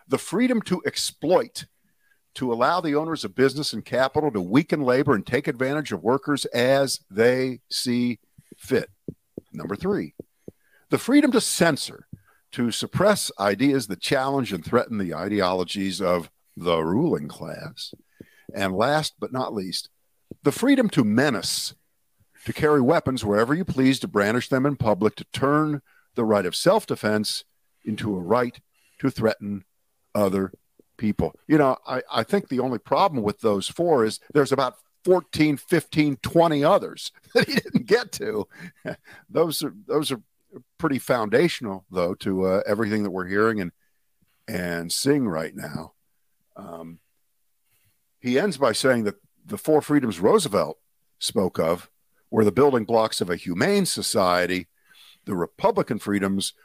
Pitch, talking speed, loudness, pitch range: 130 Hz, 150 wpm, -23 LUFS, 105-150 Hz